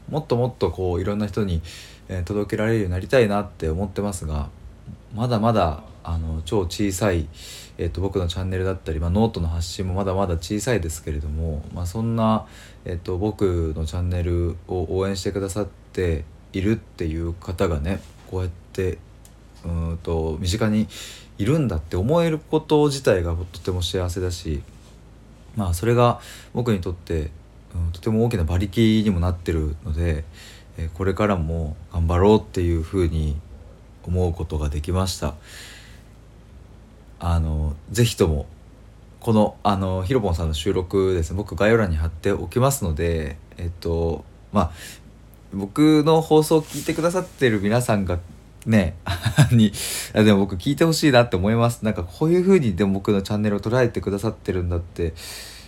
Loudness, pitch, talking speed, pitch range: -23 LUFS, 95 Hz, 330 characters per minute, 85-110 Hz